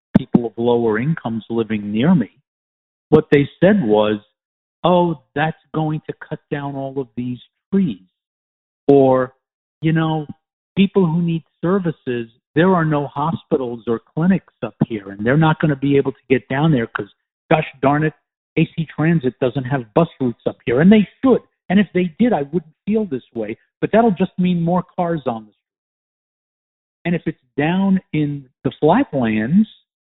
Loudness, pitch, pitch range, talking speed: -18 LUFS, 150 Hz, 125-175 Hz, 175 wpm